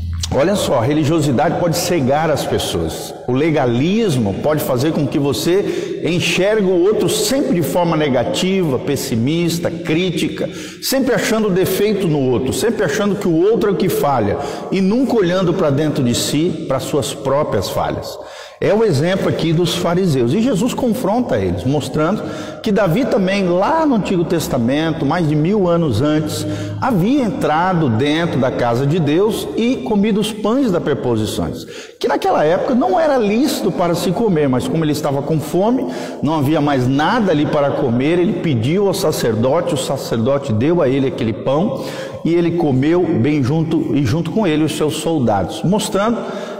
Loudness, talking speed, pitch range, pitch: -16 LUFS, 170 wpm, 145-195 Hz, 165 Hz